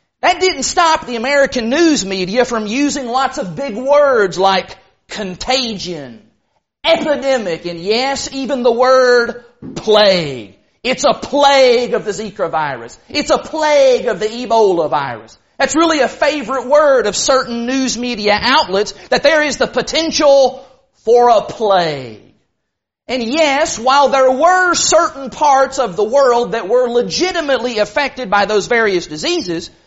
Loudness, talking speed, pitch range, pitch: -14 LUFS, 145 wpm, 215-285 Hz, 255 Hz